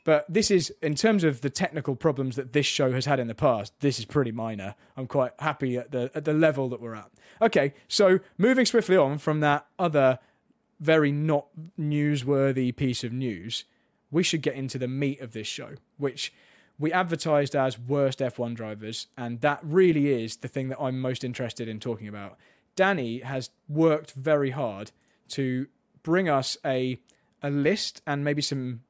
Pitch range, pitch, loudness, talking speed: 130-155 Hz, 140 Hz, -26 LUFS, 185 wpm